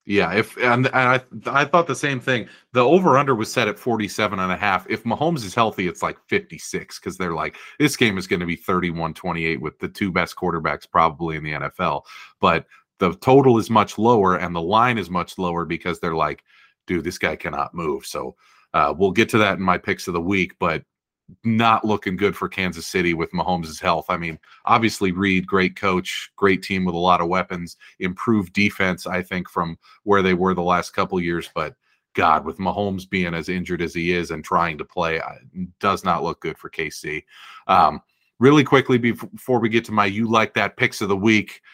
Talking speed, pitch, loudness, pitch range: 215 wpm, 95 Hz, -21 LUFS, 90-115 Hz